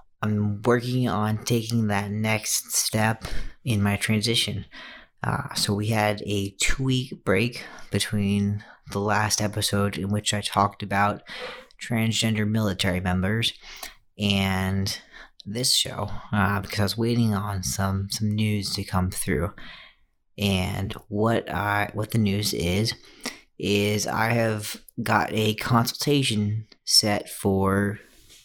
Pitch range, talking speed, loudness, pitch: 100-110 Hz, 125 wpm, -25 LUFS, 105 Hz